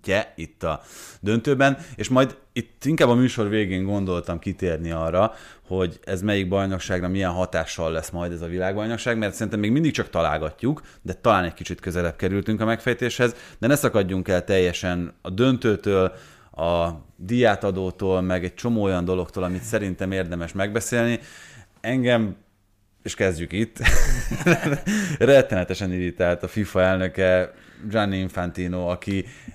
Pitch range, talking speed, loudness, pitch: 90-115 Hz, 140 wpm, -23 LUFS, 95 Hz